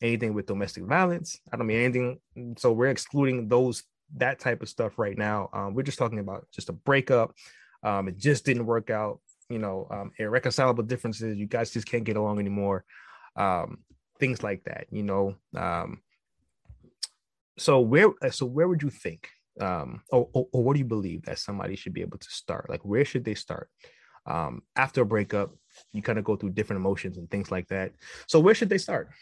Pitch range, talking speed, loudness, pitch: 100-130 Hz, 200 wpm, -28 LUFS, 115 Hz